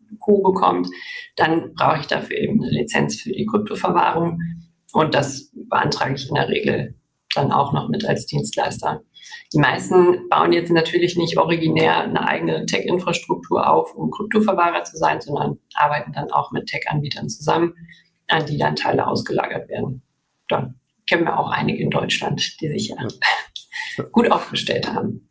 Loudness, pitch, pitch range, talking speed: -20 LUFS, 170 Hz, 165-200 Hz, 155 wpm